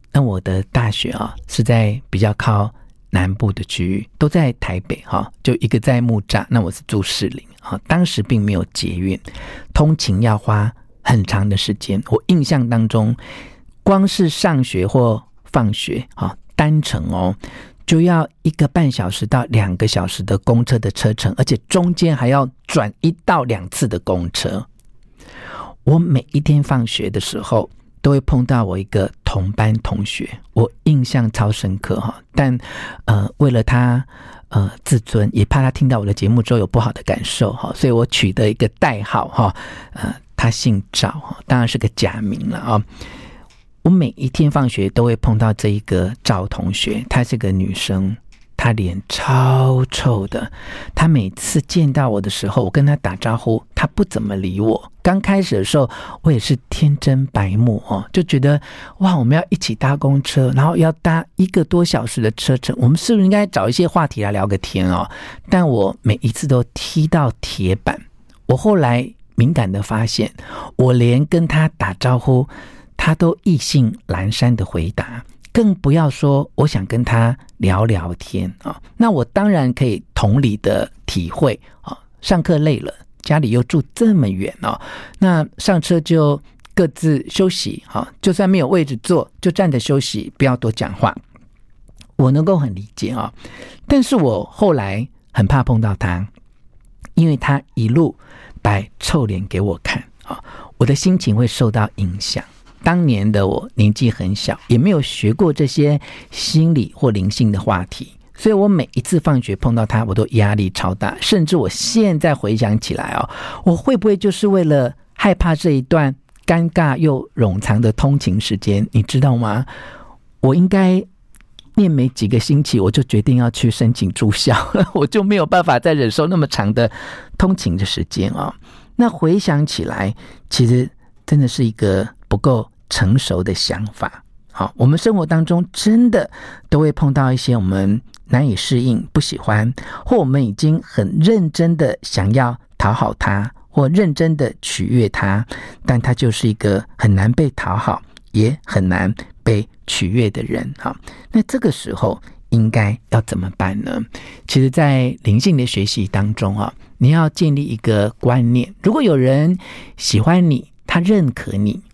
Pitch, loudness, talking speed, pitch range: 125 Hz, -17 LUFS, 240 characters per minute, 105-150 Hz